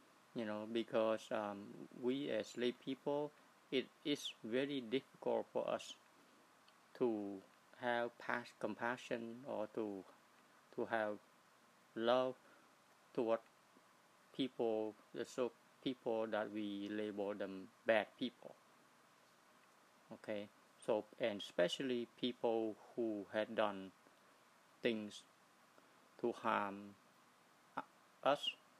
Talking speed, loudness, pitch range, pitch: 95 wpm, -43 LUFS, 105-125 Hz, 115 Hz